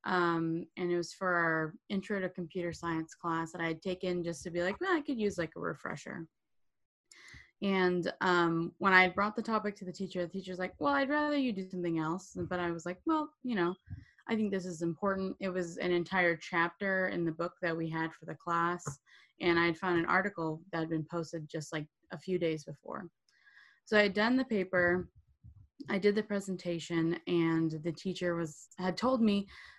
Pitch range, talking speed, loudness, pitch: 165-195 Hz, 215 wpm, -33 LUFS, 175 Hz